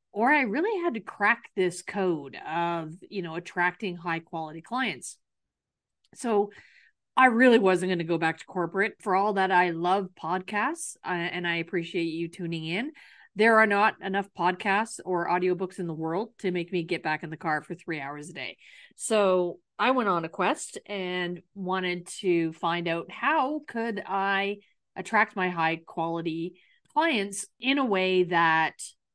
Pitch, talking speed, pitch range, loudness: 185 Hz, 175 wpm, 170-205 Hz, -27 LUFS